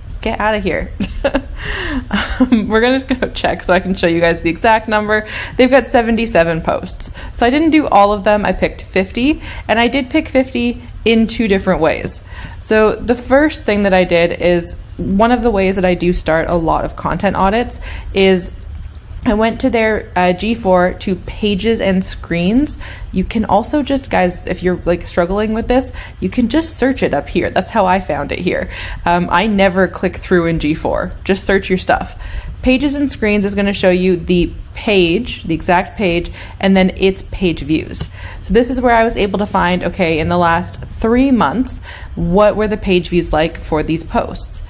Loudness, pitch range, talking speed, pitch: -15 LUFS, 175-230 Hz, 205 wpm, 195 Hz